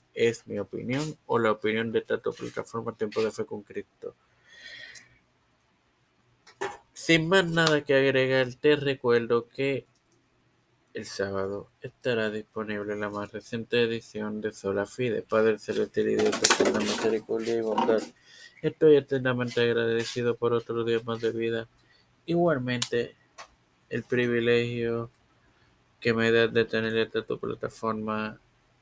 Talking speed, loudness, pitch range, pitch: 130 wpm, -27 LUFS, 110-130 Hz, 115 Hz